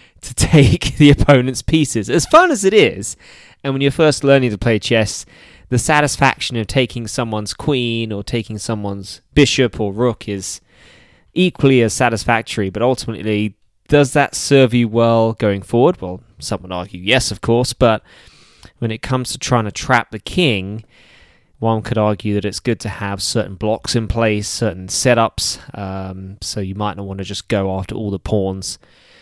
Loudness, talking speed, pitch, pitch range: -16 LUFS, 180 wpm, 115 Hz, 100-130 Hz